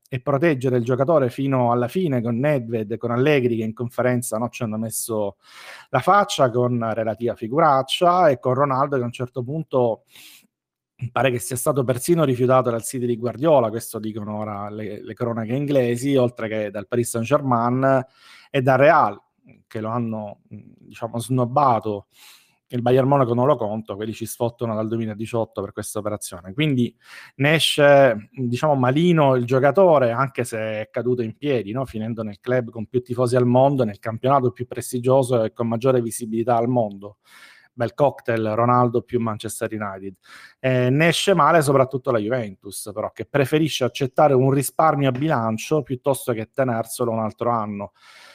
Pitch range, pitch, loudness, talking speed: 115-135 Hz, 125 Hz, -21 LUFS, 170 wpm